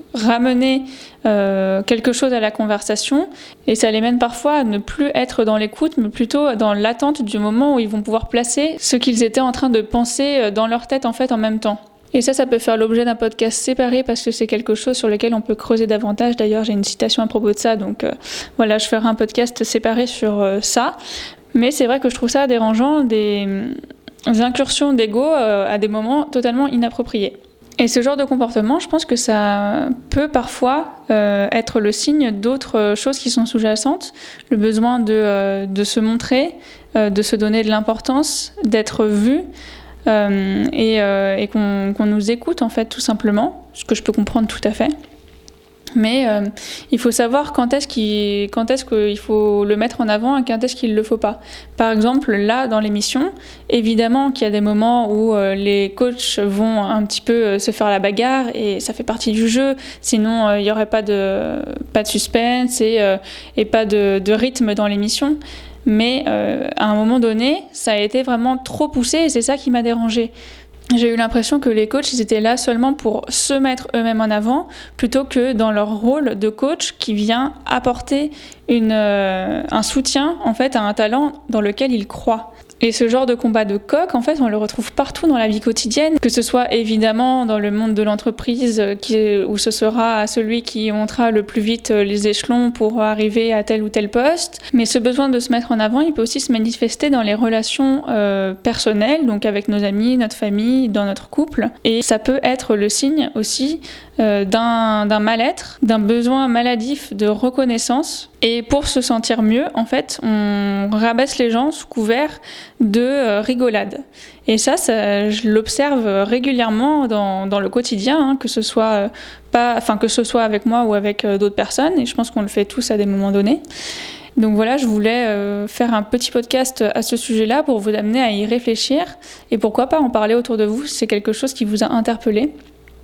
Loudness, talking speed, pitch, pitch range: -17 LUFS, 205 wpm, 230 Hz, 215-260 Hz